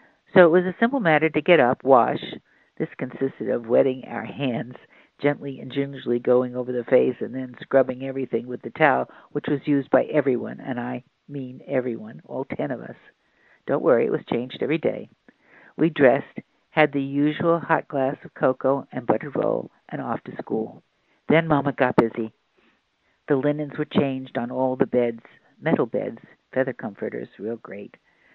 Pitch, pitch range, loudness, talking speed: 135 Hz, 125-150 Hz, -23 LUFS, 180 wpm